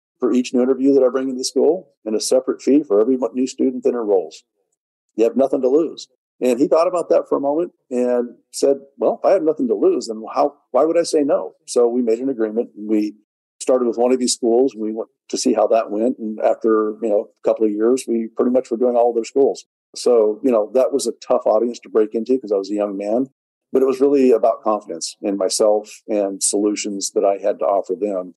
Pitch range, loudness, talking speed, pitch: 110-135 Hz, -19 LUFS, 250 wpm, 120 Hz